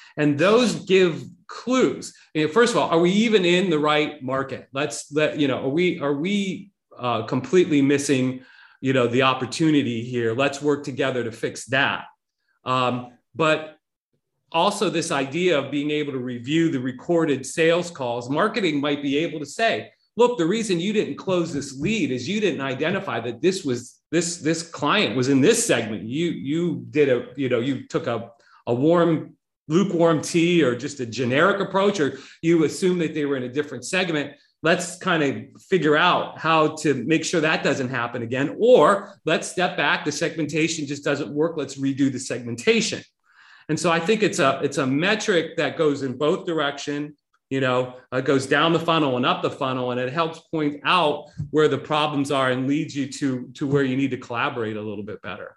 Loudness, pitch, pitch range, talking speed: -22 LUFS, 150 Hz, 135-165 Hz, 195 wpm